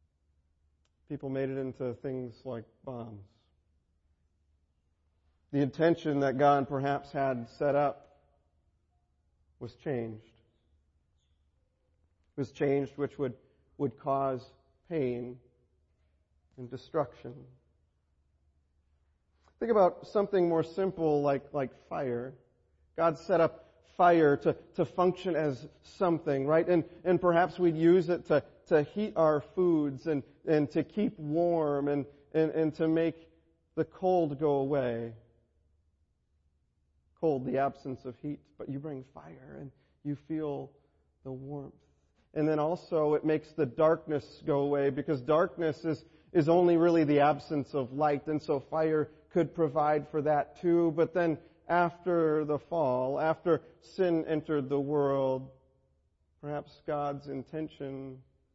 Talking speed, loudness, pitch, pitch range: 125 wpm, -30 LUFS, 140 Hz, 110-160 Hz